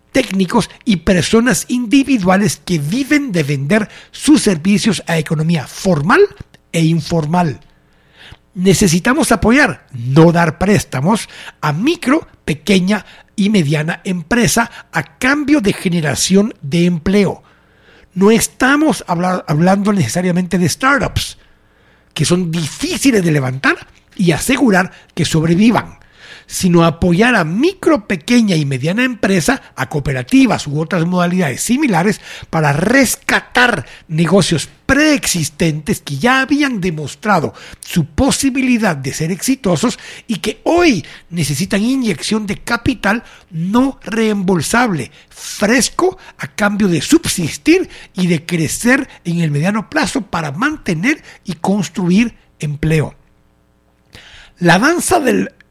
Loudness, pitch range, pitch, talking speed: -14 LUFS, 165-240 Hz, 190 Hz, 110 wpm